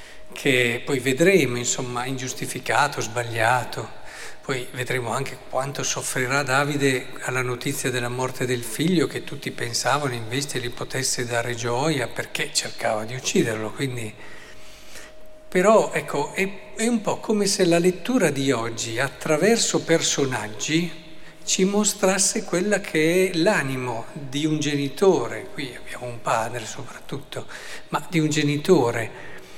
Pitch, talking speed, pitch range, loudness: 140 Hz, 130 wpm, 125-165 Hz, -23 LUFS